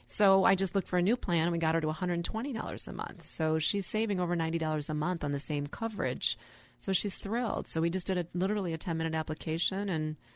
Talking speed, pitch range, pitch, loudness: 230 wpm, 160-195 Hz, 175 Hz, -32 LUFS